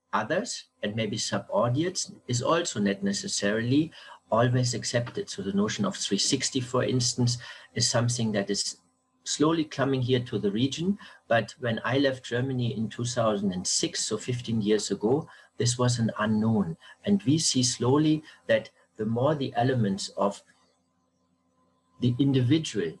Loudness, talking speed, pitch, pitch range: -27 LUFS, 140 wpm, 120 Hz, 110-140 Hz